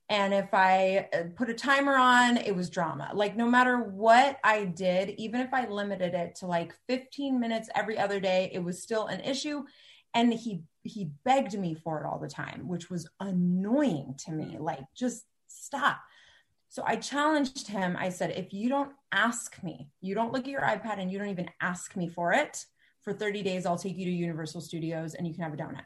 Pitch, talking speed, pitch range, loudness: 195 Hz, 210 wpm, 175-235 Hz, -29 LUFS